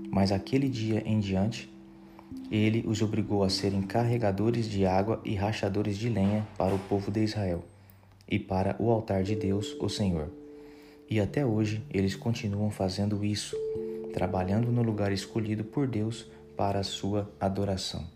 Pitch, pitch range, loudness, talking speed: 105 Hz, 95-110 Hz, -30 LUFS, 155 wpm